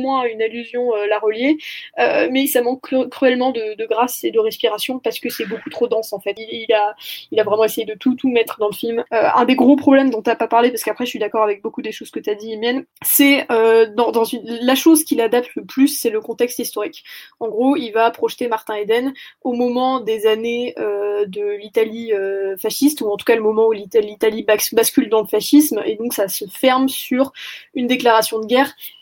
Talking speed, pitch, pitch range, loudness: 245 wpm, 230 Hz, 220-260 Hz, -17 LUFS